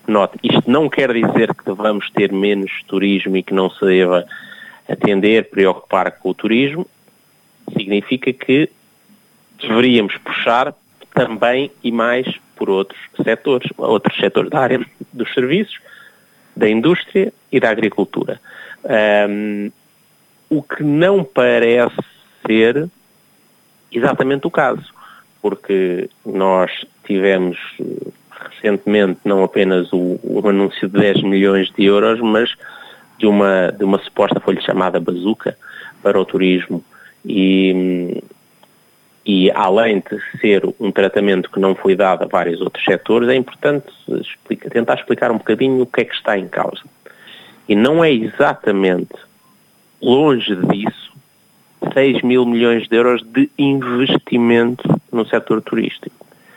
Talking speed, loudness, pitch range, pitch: 130 wpm, -16 LUFS, 95-125 Hz, 105 Hz